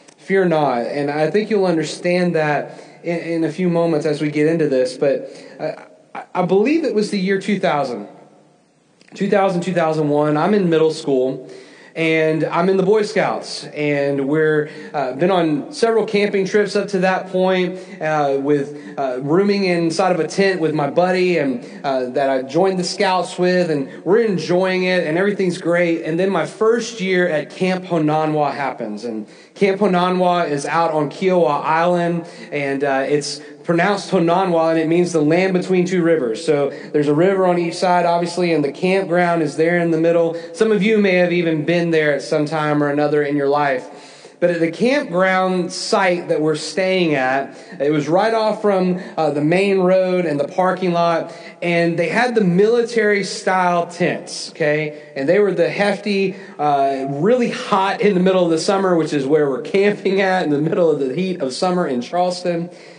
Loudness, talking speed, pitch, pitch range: -18 LUFS, 190 wpm, 175 Hz, 155-190 Hz